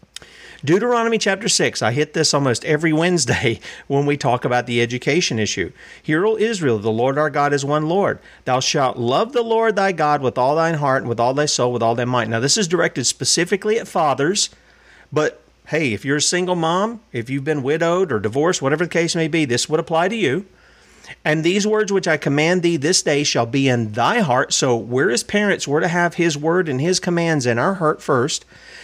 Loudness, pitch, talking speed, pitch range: -18 LUFS, 155 Hz, 220 wpm, 130-180 Hz